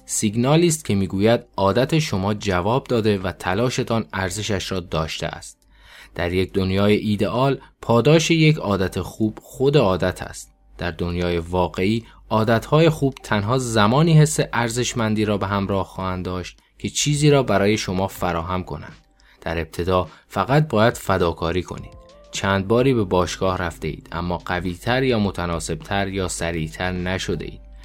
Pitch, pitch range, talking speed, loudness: 100 Hz, 90-115 Hz, 140 wpm, -21 LUFS